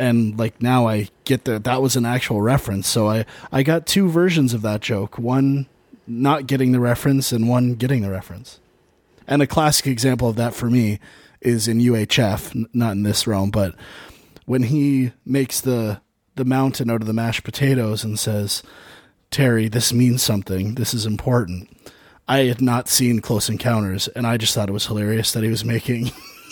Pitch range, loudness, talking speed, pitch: 110-130 Hz, -19 LUFS, 190 wpm, 120 Hz